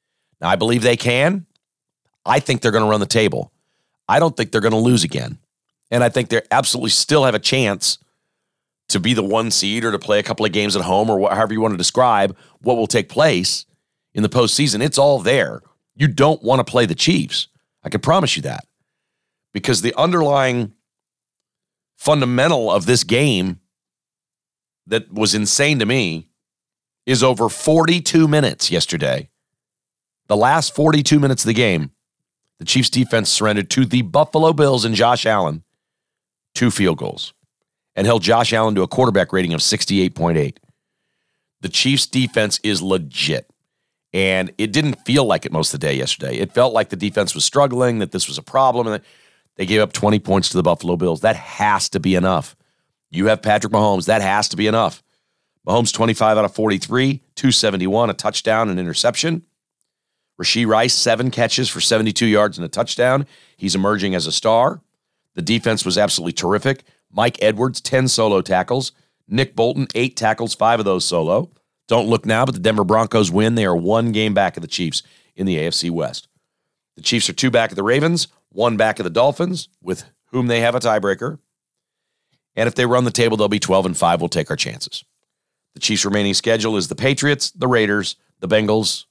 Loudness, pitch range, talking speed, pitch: -17 LUFS, 100-130 Hz, 190 wpm, 115 Hz